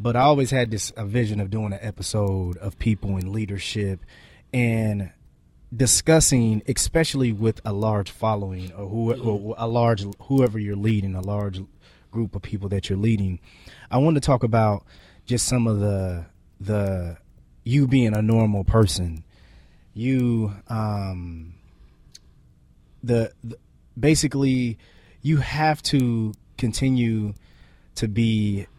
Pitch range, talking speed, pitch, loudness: 95-120 Hz, 135 wpm, 110 Hz, -23 LUFS